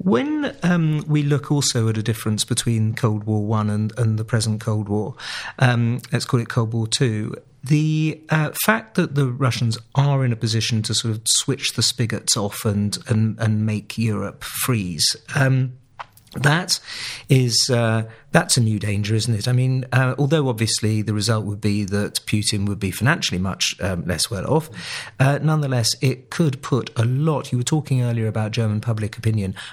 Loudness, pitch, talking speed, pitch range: -21 LUFS, 120 Hz, 180 wpm, 110-135 Hz